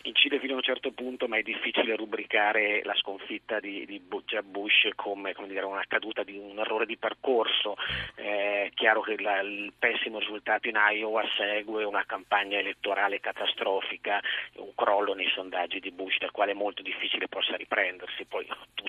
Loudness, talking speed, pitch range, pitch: -28 LUFS, 160 wpm, 100-110 Hz, 105 Hz